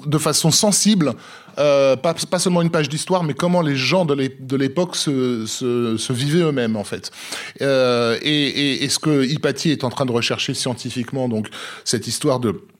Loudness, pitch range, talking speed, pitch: -19 LUFS, 125-160 Hz, 190 wpm, 140 Hz